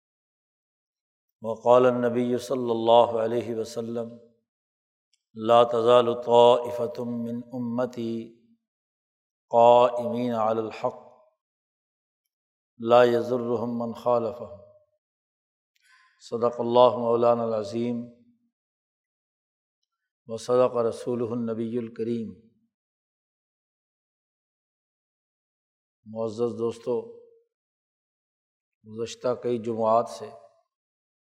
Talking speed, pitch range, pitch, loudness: 55 wpm, 115-125 Hz, 120 Hz, -24 LUFS